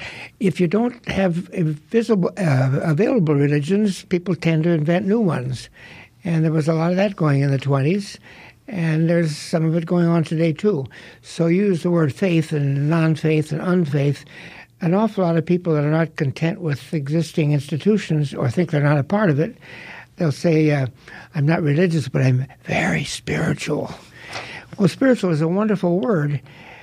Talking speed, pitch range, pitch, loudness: 180 wpm, 150-180 Hz, 165 Hz, -20 LUFS